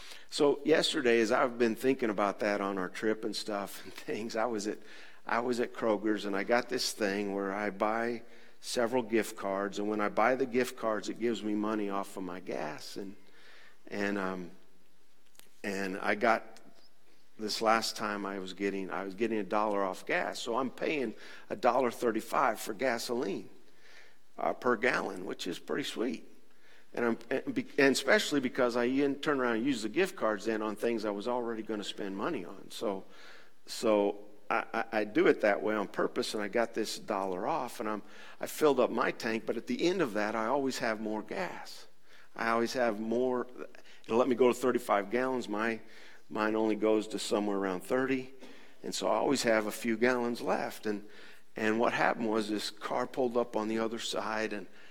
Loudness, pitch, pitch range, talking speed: -32 LUFS, 110 Hz, 105-120 Hz, 200 wpm